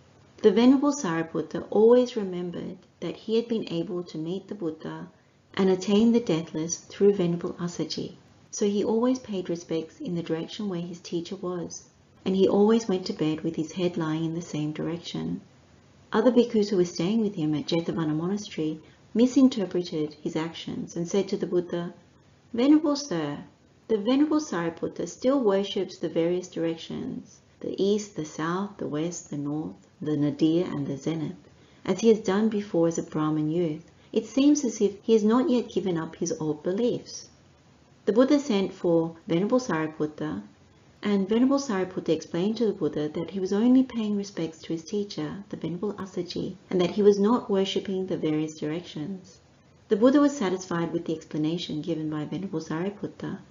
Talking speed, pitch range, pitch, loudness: 175 wpm, 160-210 Hz, 180 Hz, -27 LUFS